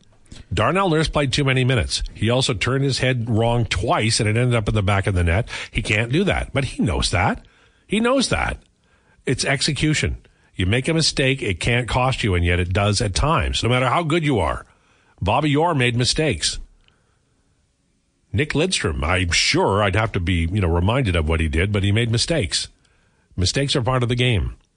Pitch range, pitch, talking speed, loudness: 95-130 Hz, 110 Hz, 205 wpm, -20 LUFS